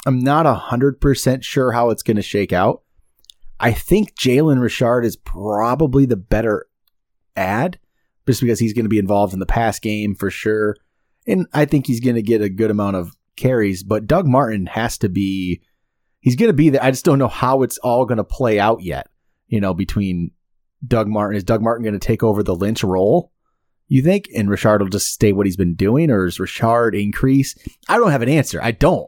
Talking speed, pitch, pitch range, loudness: 205 wpm, 110 Hz, 100-130 Hz, -17 LUFS